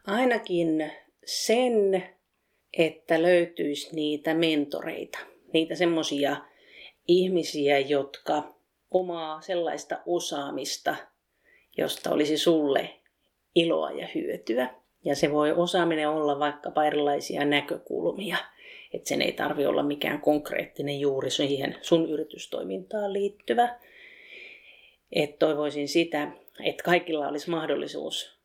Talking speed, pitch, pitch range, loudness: 95 wpm, 160 Hz, 150-185 Hz, -27 LUFS